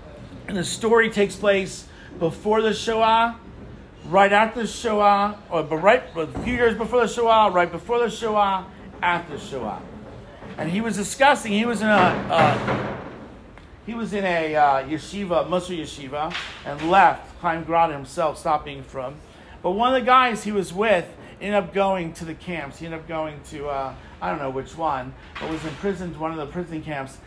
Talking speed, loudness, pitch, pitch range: 185 wpm, -22 LUFS, 185 Hz, 160-215 Hz